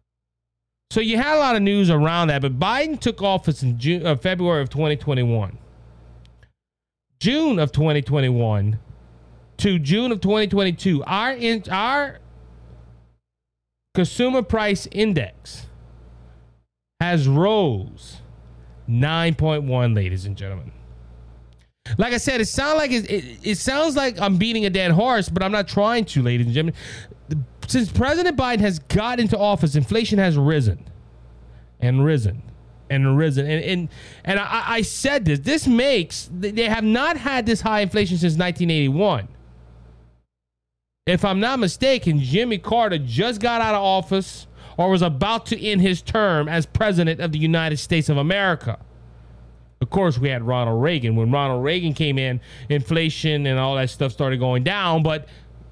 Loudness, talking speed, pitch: -20 LUFS, 150 wpm, 155 Hz